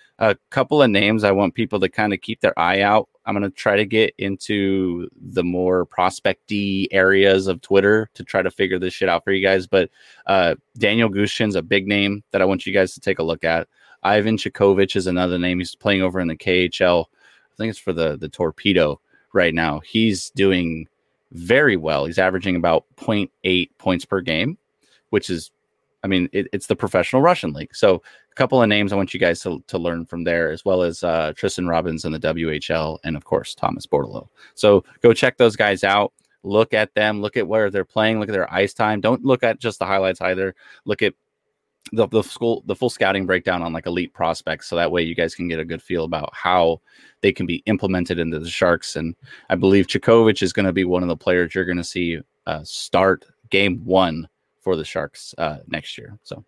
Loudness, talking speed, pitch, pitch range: -20 LUFS, 220 wpm, 95 Hz, 85-105 Hz